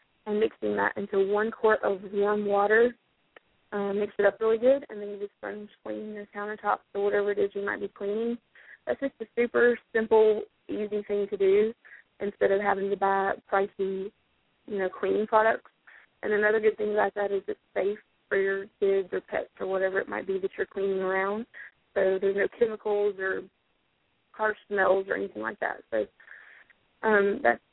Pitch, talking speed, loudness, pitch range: 205 Hz, 190 wpm, -28 LUFS, 195-220 Hz